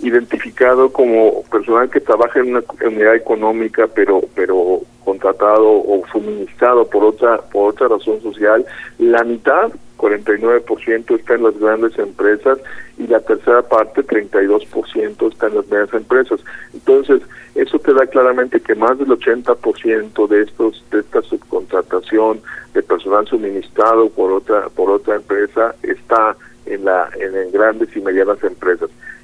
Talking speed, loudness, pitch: 145 wpm, -15 LUFS, 380 Hz